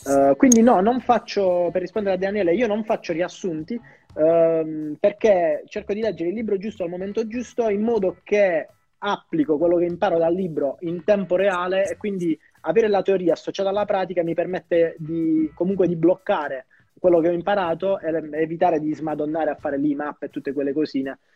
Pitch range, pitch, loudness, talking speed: 160-205 Hz, 180 Hz, -22 LUFS, 185 wpm